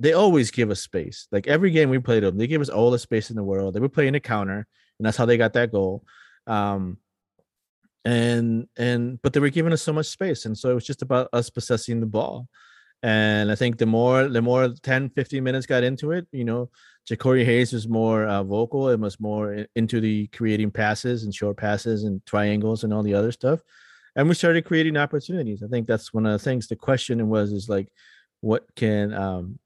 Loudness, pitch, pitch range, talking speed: -23 LUFS, 115 Hz, 105-130 Hz, 225 wpm